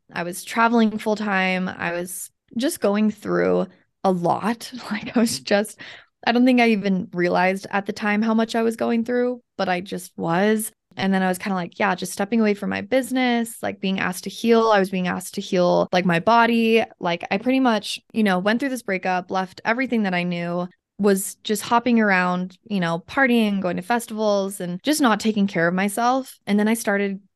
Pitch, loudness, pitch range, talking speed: 205 Hz, -21 LUFS, 185-230 Hz, 215 wpm